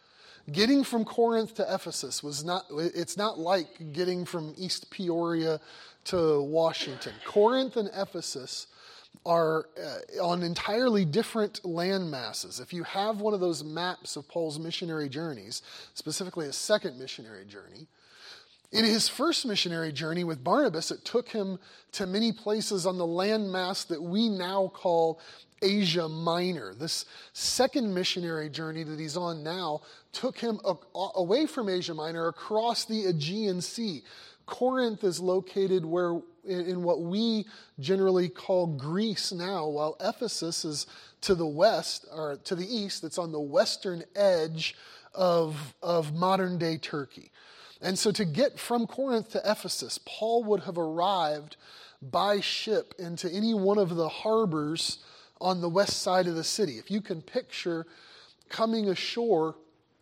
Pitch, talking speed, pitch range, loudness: 180 Hz, 150 wpm, 165-210 Hz, -29 LUFS